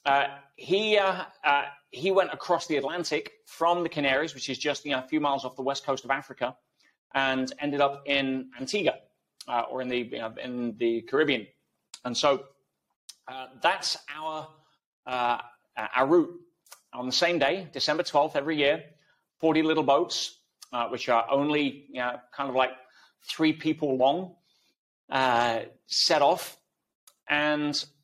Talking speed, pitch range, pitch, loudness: 160 wpm, 130-155 Hz, 140 Hz, -27 LUFS